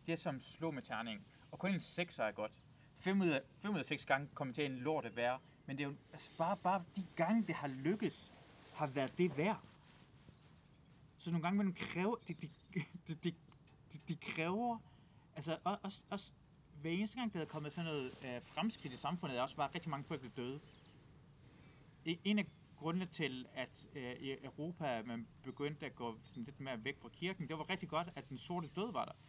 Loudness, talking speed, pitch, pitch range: -42 LUFS, 205 wpm, 155 Hz, 140-175 Hz